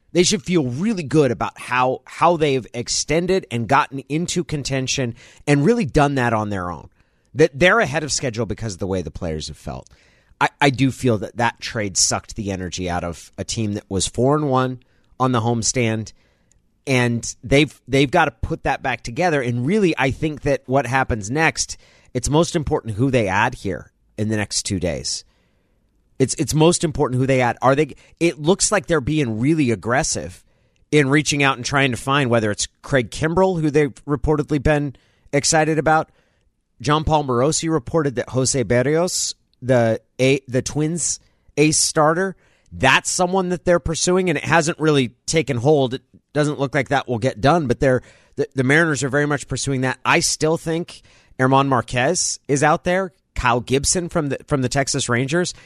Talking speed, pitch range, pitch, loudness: 190 wpm, 115-155 Hz, 135 Hz, -19 LUFS